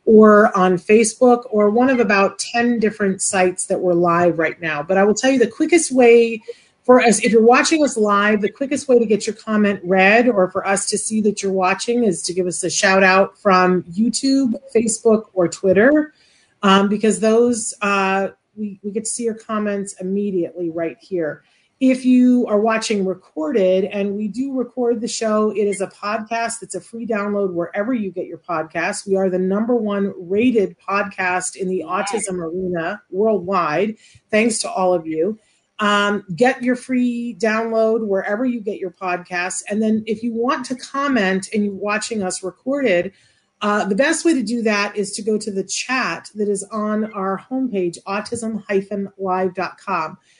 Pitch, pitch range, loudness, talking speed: 210 Hz, 190-230 Hz, -18 LUFS, 185 wpm